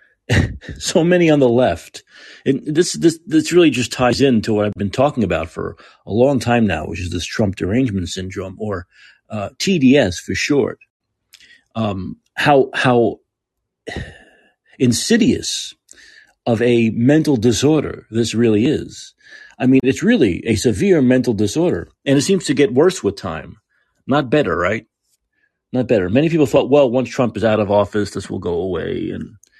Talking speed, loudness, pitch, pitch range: 165 wpm, -17 LUFS, 125 Hz, 105-150 Hz